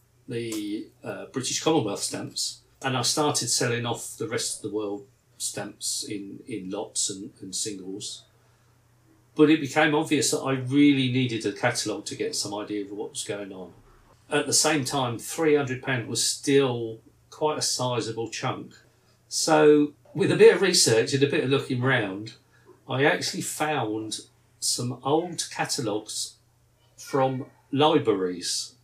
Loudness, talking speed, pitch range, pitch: -25 LUFS, 150 wpm, 115-145 Hz, 125 Hz